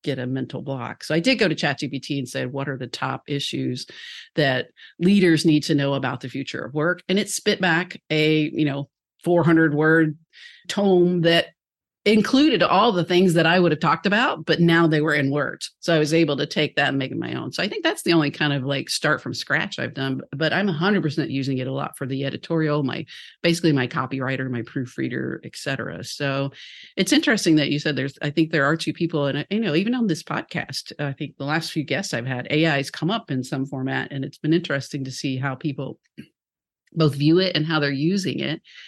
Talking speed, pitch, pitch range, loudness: 230 wpm, 155 Hz, 140-170 Hz, -22 LUFS